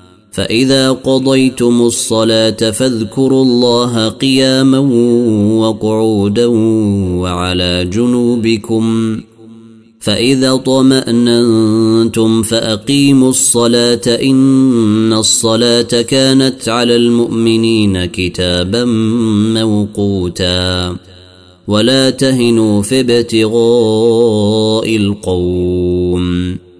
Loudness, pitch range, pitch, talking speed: -11 LUFS, 105-120 Hz, 115 Hz, 55 wpm